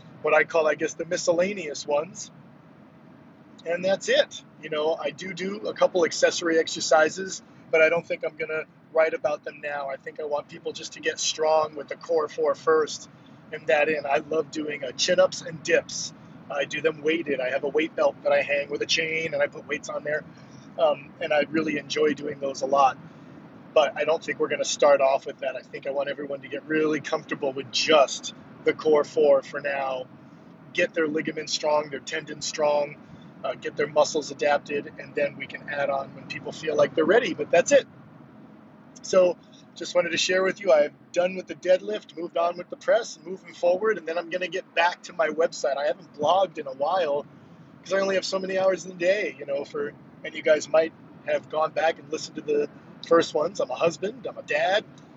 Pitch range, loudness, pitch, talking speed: 145-185 Hz, -25 LUFS, 160 Hz, 220 wpm